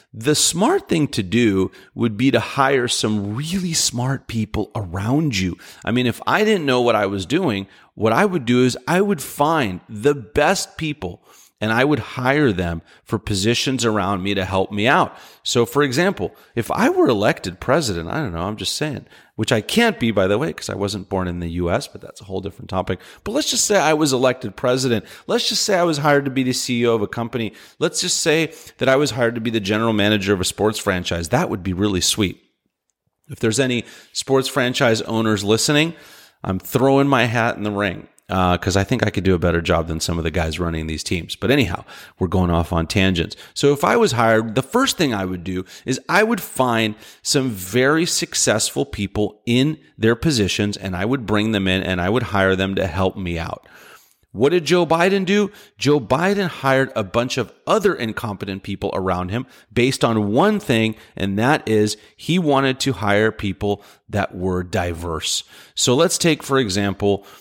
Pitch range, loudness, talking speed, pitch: 100-140 Hz, -19 LUFS, 210 wpm, 115 Hz